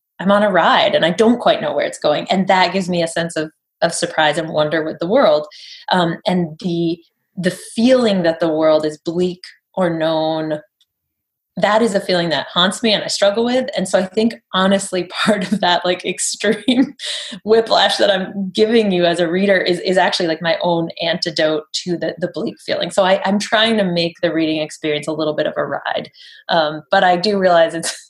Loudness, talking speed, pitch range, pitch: -16 LUFS, 215 wpm, 165-205 Hz, 180 Hz